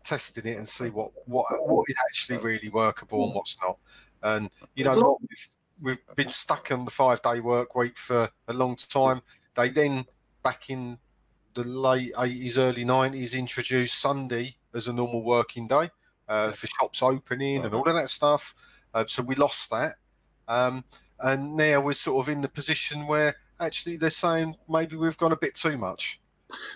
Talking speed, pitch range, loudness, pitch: 180 wpm, 120-145 Hz, -26 LUFS, 130 Hz